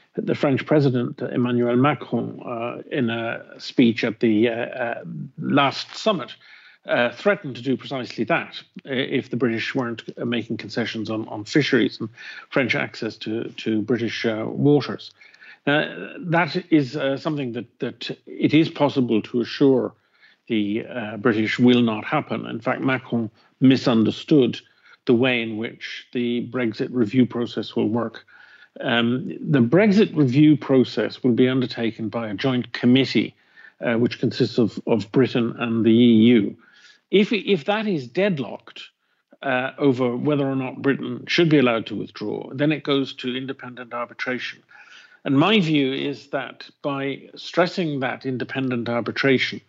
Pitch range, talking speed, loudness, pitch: 115-140 Hz, 150 wpm, -22 LUFS, 125 Hz